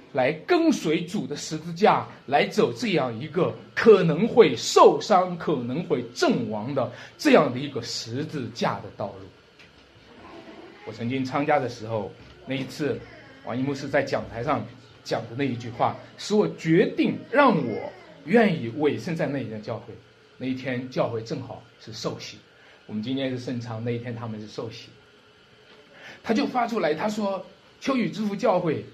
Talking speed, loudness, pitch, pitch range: 240 characters per minute, -25 LUFS, 140 Hz, 120-180 Hz